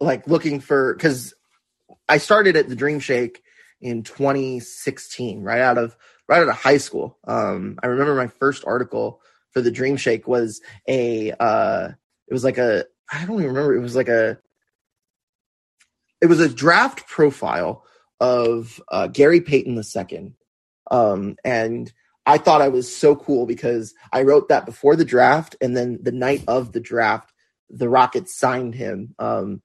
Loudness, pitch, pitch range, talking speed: -19 LUFS, 130 Hz, 120-145 Hz, 170 wpm